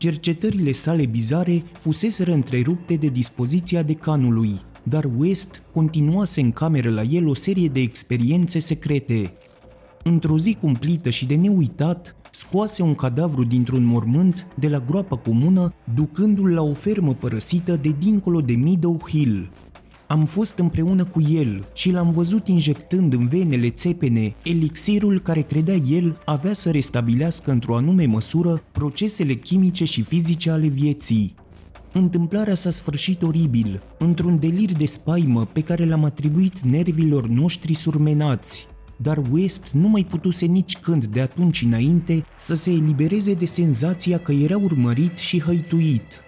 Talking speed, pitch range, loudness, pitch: 140 wpm, 135-175 Hz, -20 LUFS, 160 Hz